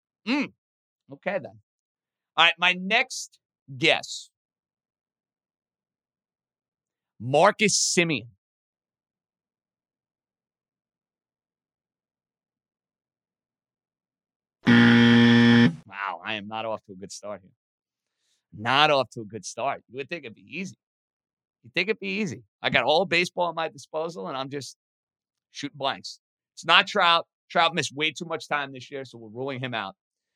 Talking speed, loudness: 130 wpm, -23 LUFS